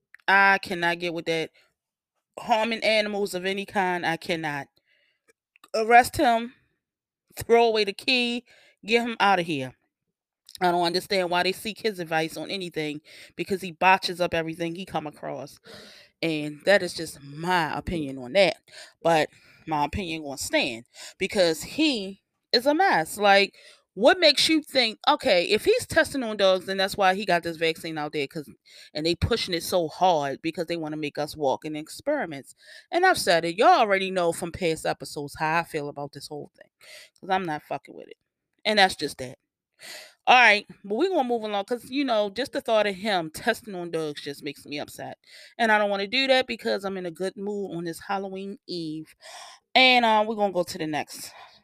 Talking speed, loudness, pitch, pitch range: 200 wpm, -24 LUFS, 185 Hz, 160-225 Hz